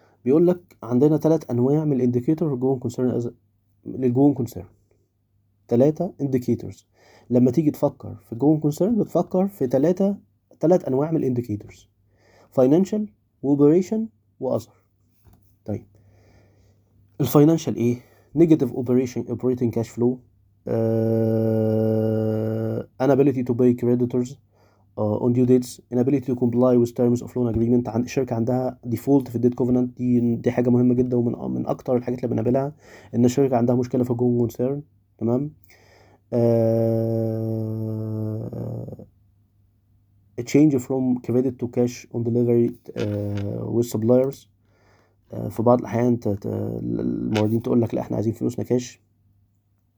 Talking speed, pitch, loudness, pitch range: 125 wpm, 120 Hz, -22 LUFS, 105-125 Hz